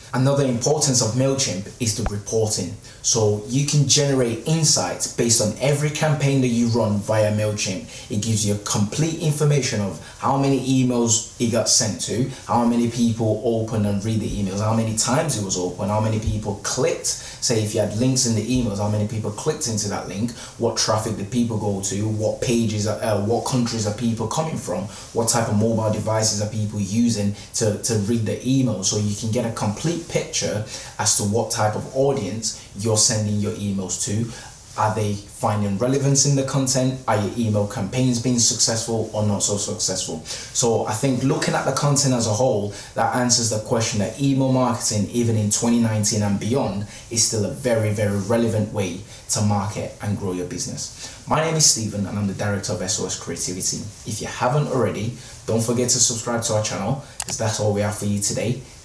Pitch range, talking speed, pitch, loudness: 105-125 Hz, 200 wpm, 115 Hz, -21 LUFS